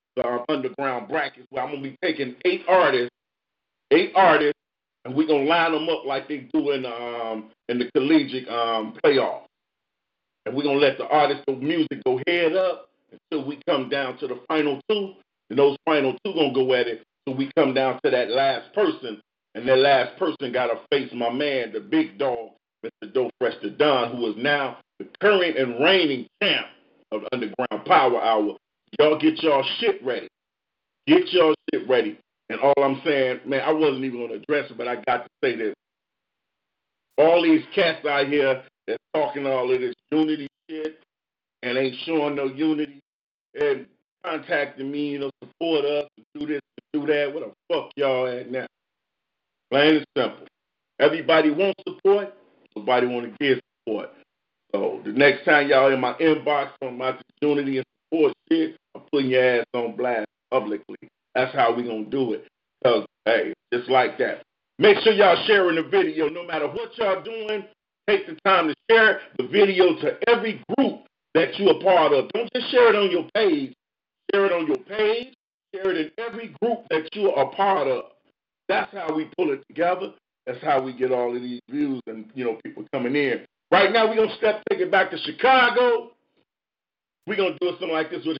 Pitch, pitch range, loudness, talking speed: 155 Hz, 135-205 Hz, -22 LUFS, 195 wpm